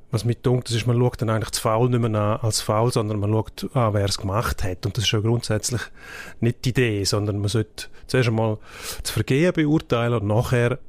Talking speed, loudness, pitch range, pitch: 225 wpm, -22 LUFS, 105-120 Hz, 115 Hz